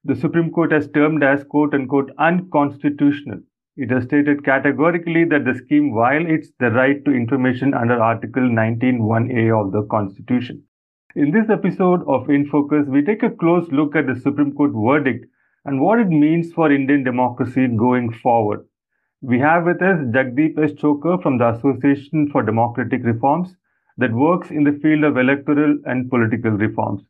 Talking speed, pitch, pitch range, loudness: 160 wpm, 140 Hz, 125-155 Hz, -18 LUFS